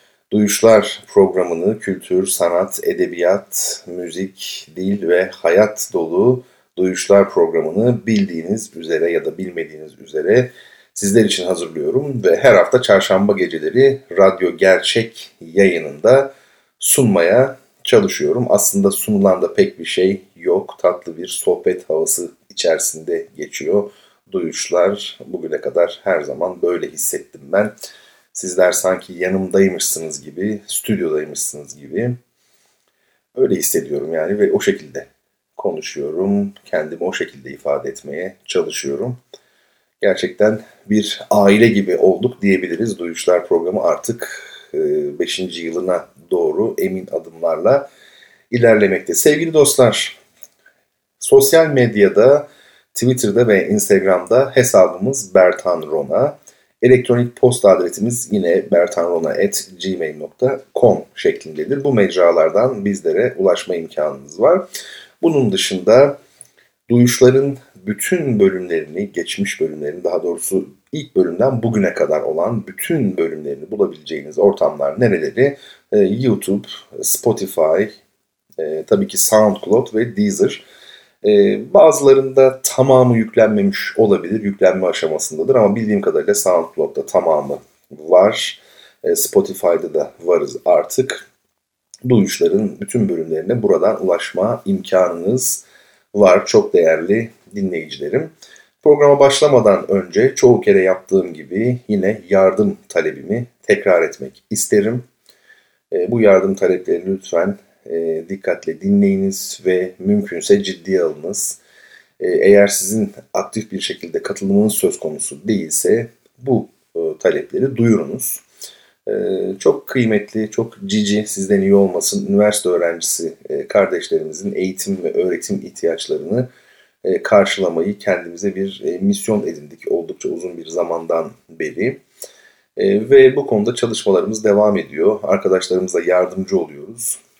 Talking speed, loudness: 105 wpm, -16 LUFS